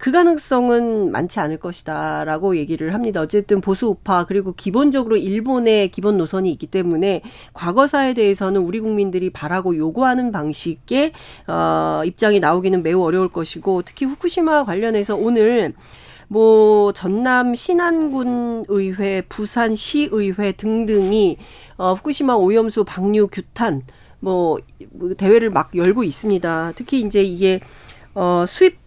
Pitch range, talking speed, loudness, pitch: 185-230 Hz, 310 characters per minute, -18 LUFS, 205 Hz